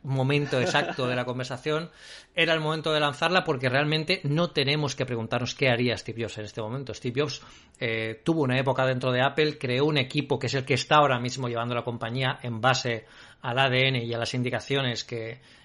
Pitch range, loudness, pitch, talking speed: 120-145 Hz, -26 LUFS, 130 Hz, 205 wpm